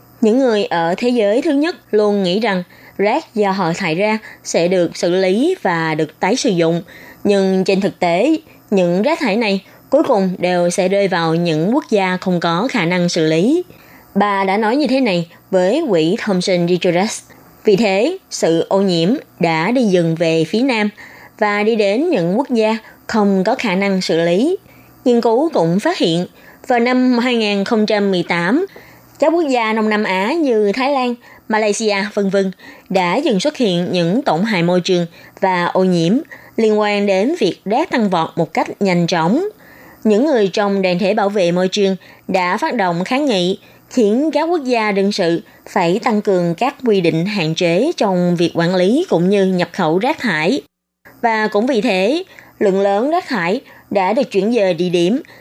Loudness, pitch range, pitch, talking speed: -16 LUFS, 180-235 Hz, 200 Hz, 190 wpm